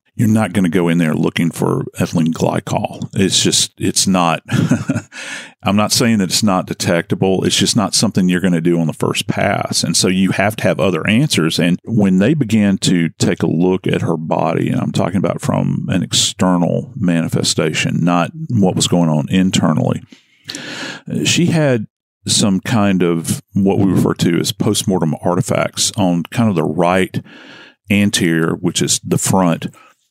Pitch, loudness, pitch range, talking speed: 95 Hz, -15 LUFS, 85-105 Hz, 175 wpm